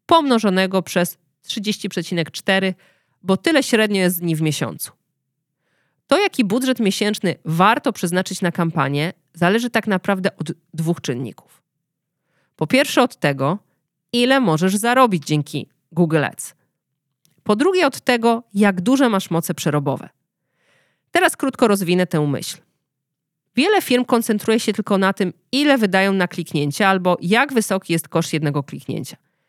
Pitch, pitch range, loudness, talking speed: 180 Hz, 160-220 Hz, -19 LUFS, 135 wpm